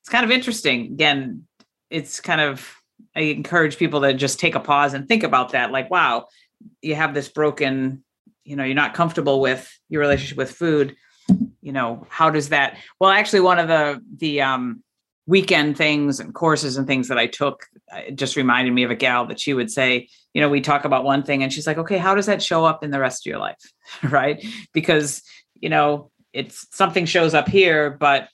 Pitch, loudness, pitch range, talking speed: 150 Hz, -19 LUFS, 140-170 Hz, 210 wpm